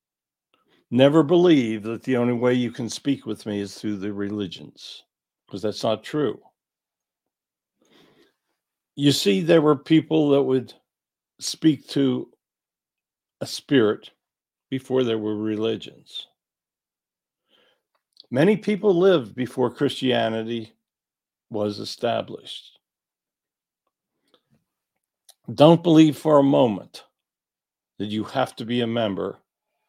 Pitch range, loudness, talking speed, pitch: 110-150 Hz, -22 LUFS, 105 wpm, 125 Hz